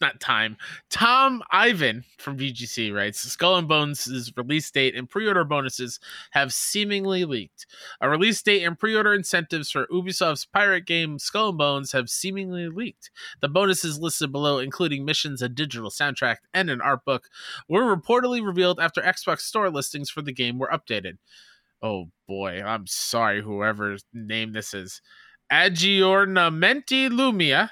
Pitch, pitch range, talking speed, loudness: 155 Hz, 125-195 Hz, 155 wpm, -23 LUFS